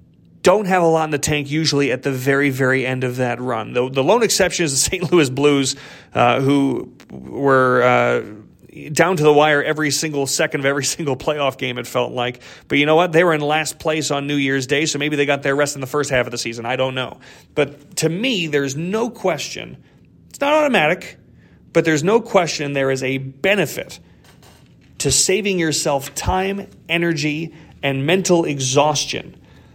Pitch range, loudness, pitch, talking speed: 135-165 Hz, -18 LUFS, 145 Hz, 200 wpm